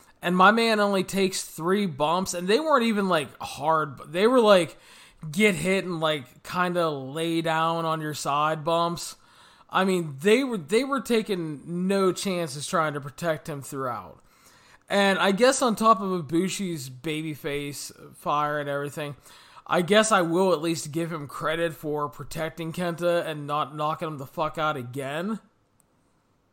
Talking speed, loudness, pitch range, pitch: 170 wpm, -25 LUFS, 150-190 Hz, 165 Hz